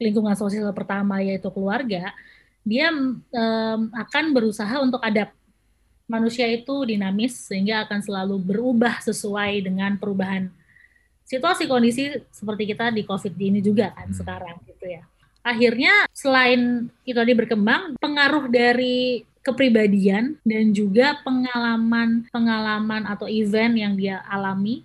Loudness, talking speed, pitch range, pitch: -21 LUFS, 120 wpm, 205-250 Hz, 225 Hz